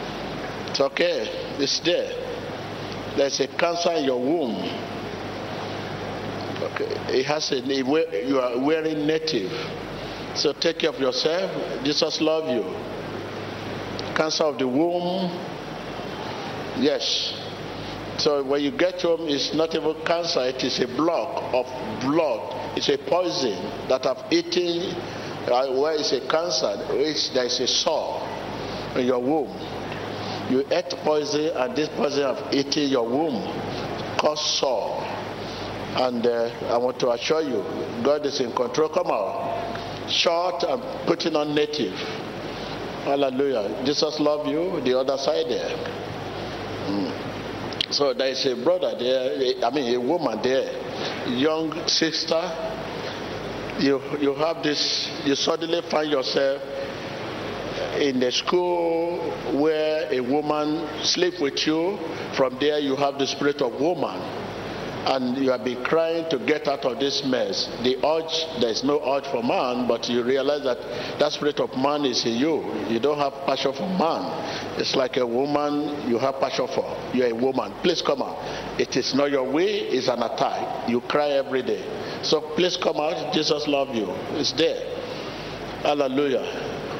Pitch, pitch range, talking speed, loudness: 145 Hz, 135-165 Hz, 150 wpm, -24 LUFS